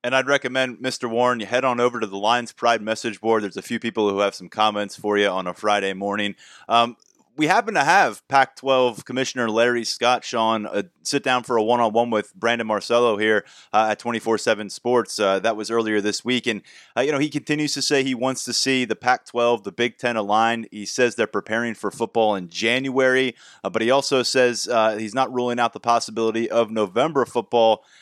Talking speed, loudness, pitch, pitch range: 215 wpm, -21 LUFS, 115 Hz, 110-125 Hz